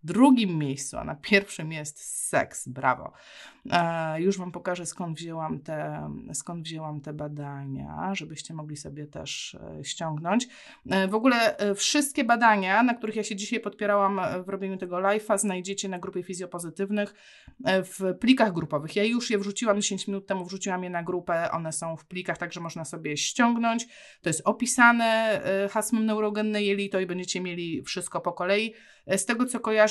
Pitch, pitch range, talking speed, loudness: 190 Hz, 170-215 Hz, 160 wpm, -27 LUFS